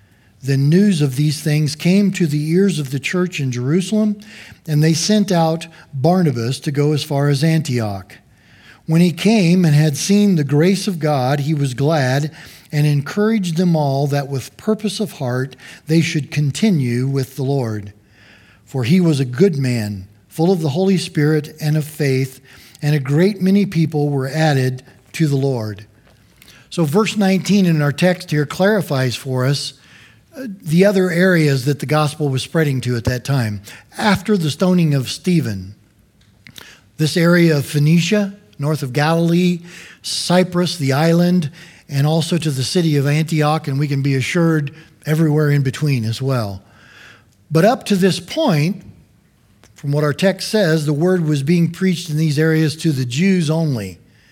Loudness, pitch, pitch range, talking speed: -17 LUFS, 150 Hz, 135-175 Hz, 170 wpm